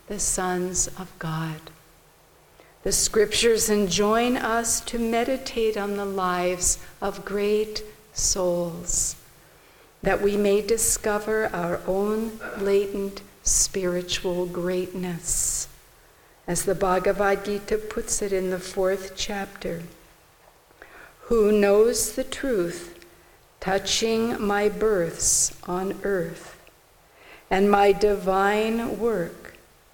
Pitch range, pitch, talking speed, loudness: 180-215 Hz, 200 Hz, 95 wpm, -24 LUFS